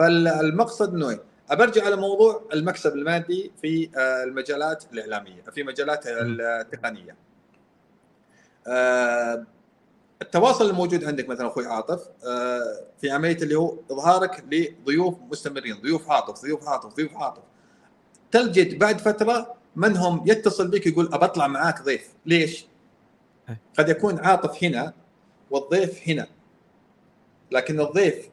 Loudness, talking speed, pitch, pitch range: -23 LUFS, 110 wpm, 165 Hz, 140-195 Hz